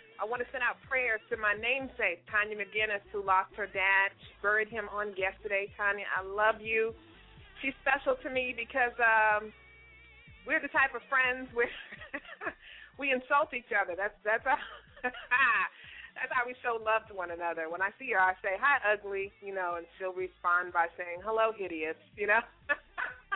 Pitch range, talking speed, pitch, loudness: 195-250 Hz, 180 wpm, 215 Hz, -31 LUFS